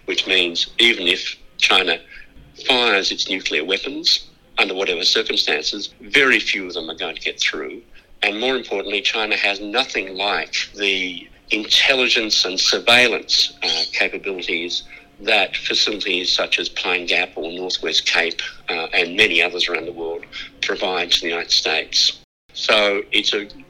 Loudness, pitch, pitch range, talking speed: -17 LUFS, 95 Hz, 90-100 Hz, 145 wpm